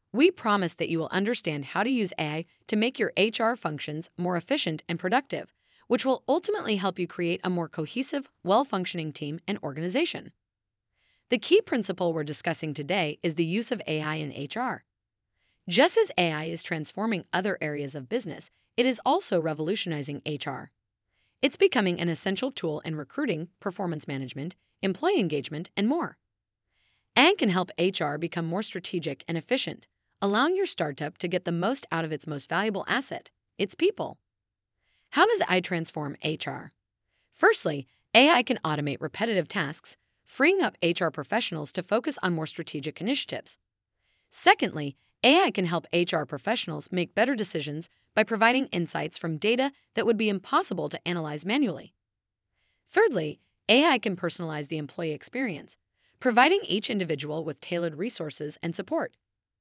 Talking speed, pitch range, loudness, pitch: 155 wpm, 155-225 Hz, -27 LUFS, 175 Hz